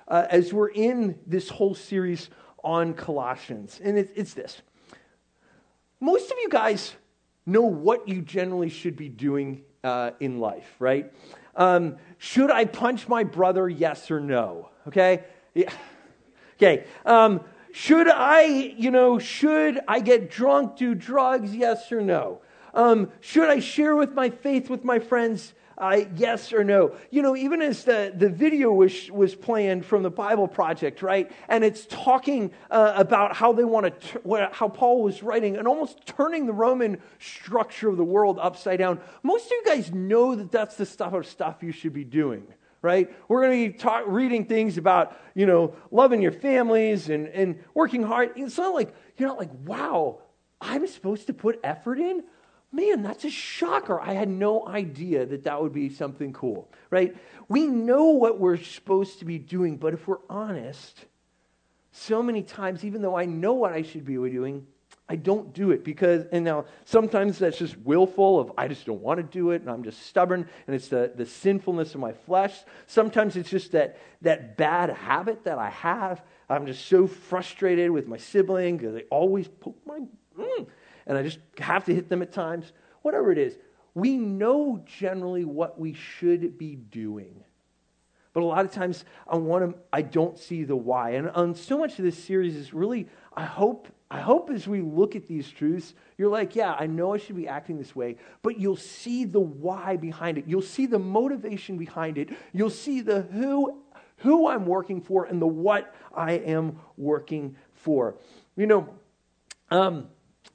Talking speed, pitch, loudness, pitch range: 185 wpm, 190 Hz, -24 LUFS, 170-230 Hz